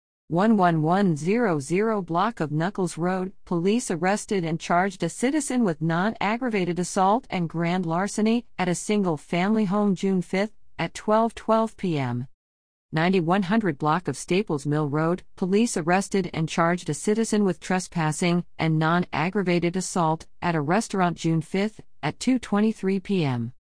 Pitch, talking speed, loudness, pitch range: 180 Hz, 135 wpm, -24 LUFS, 165-205 Hz